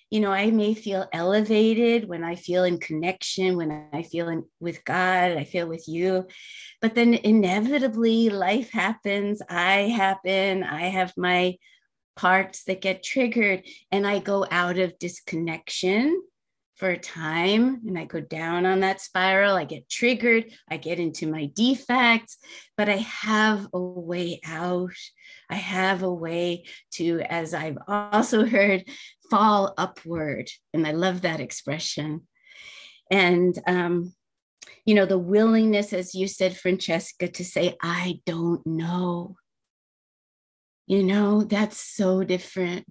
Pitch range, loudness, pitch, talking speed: 175-210 Hz, -24 LUFS, 185 Hz, 140 wpm